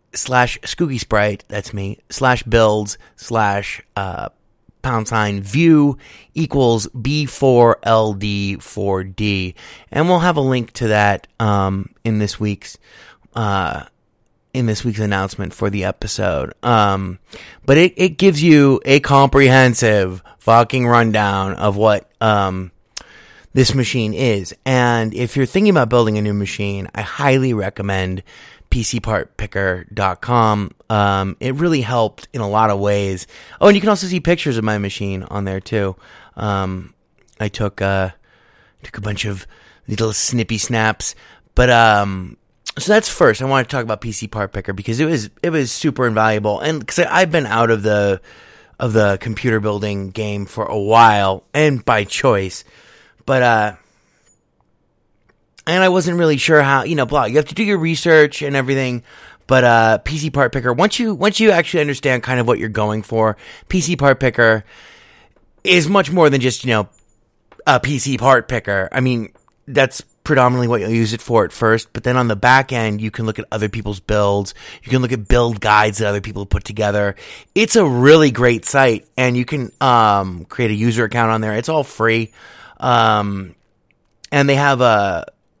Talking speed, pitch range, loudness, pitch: 170 wpm, 105-135 Hz, -16 LUFS, 115 Hz